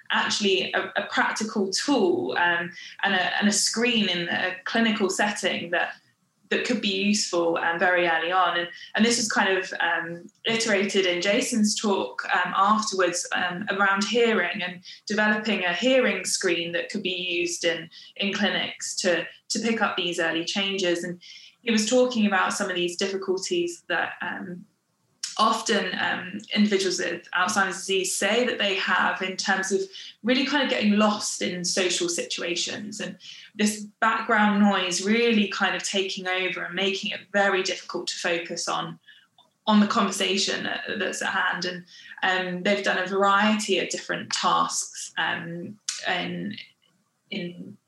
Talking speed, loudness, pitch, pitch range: 160 wpm, -24 LUFS, 195 Hz, 180-215 Hz